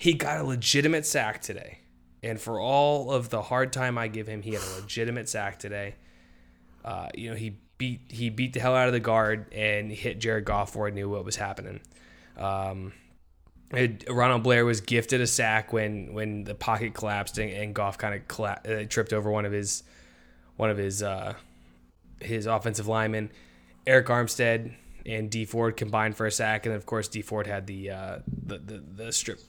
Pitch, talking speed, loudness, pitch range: 110 Hz, 195 wpm, -28 LUFS, 100-115 Hz